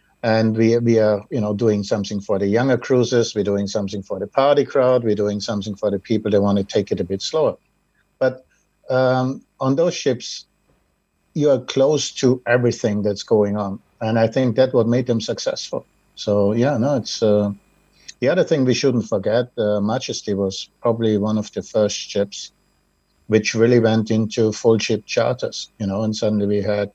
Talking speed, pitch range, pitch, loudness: 195 wpm, 105-120 Hz, 110 Hz, -19 LUFS